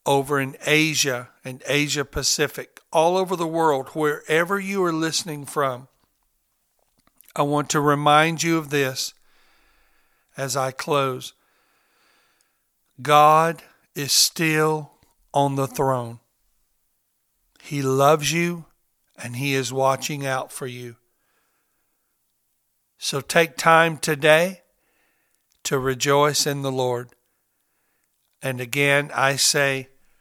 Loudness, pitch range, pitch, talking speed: -21 LUFS, 135-155 Hz, 140 Hz, 105 wpm